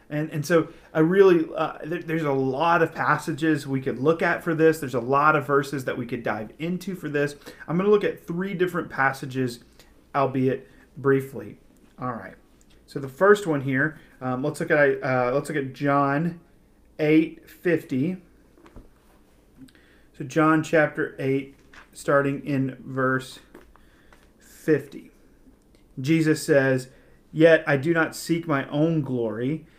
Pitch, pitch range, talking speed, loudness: 150 Hz, 135-160 Hz, 150 wpm, -24 LUFS